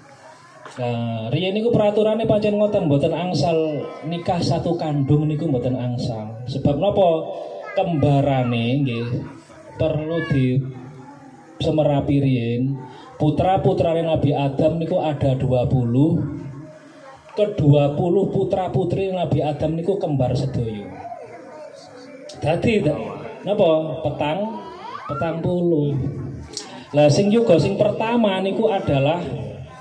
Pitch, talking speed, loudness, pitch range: 150 Hz, 95 wpm, -20 LUFS, 135-180 Hz